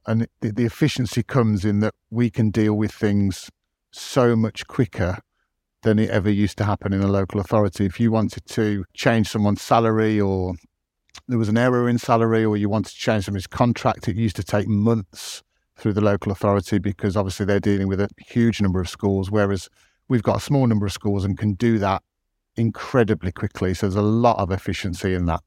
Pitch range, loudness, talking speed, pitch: 100-115 Hz, -21 LUFS, 205 wpm, 105 Hz